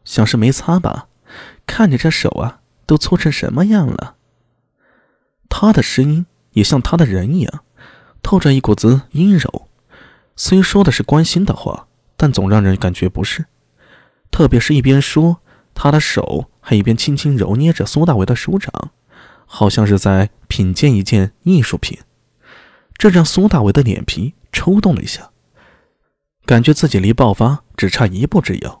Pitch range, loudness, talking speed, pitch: 110-165 Hz, -14 LUFS, 230 characters per minute, 140 Hz